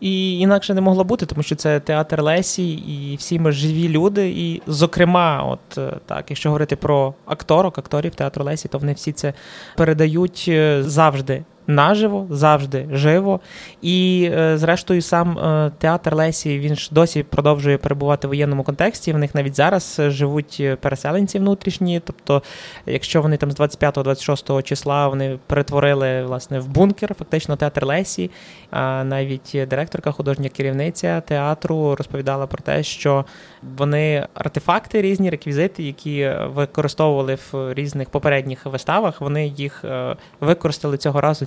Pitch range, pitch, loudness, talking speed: 140-170 Hz, 150 Hz, -19 LUFS, 135 wpm